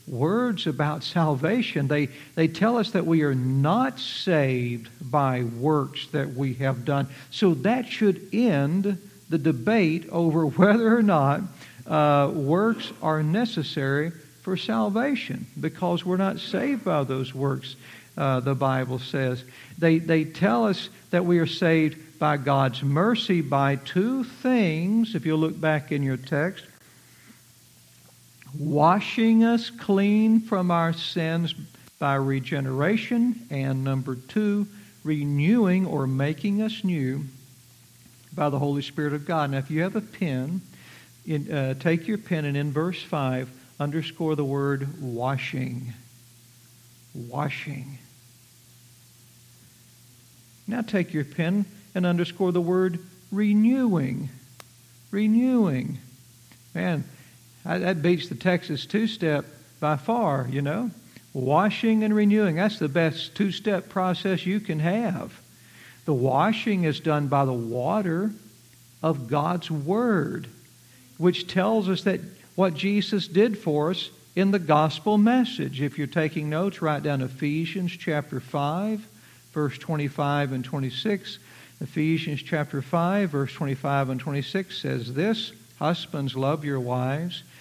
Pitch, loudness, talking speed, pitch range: 155 Hz, -25 LUFS, 130 wpm, 135-190 Hz